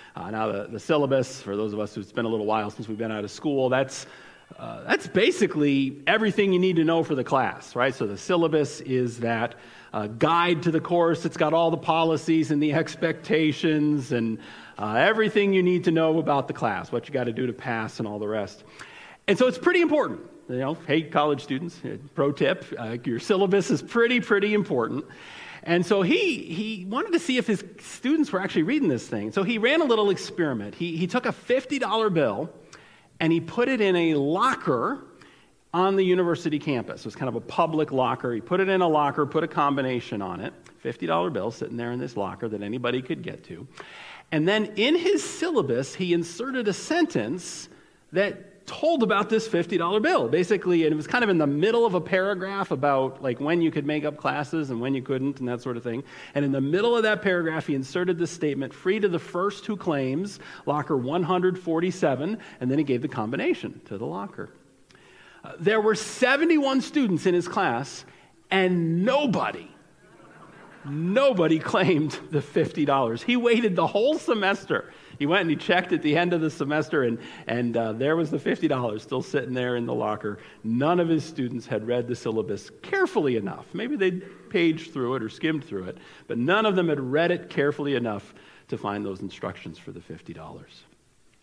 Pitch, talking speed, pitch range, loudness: 160 Hz, 205 wpm, 130-195 Hz, -25 LUFS